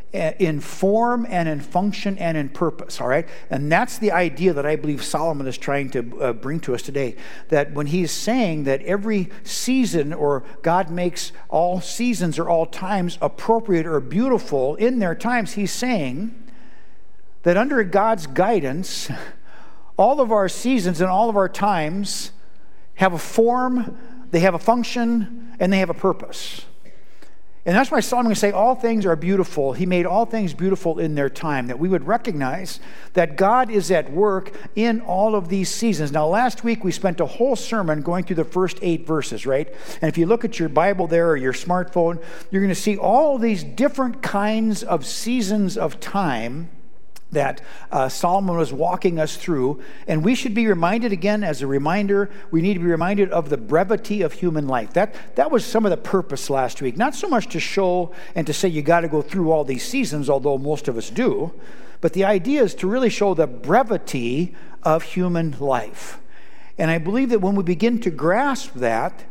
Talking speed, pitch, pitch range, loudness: 190 wpm, 185 Hz, 160-220 Hz, -21 LUFS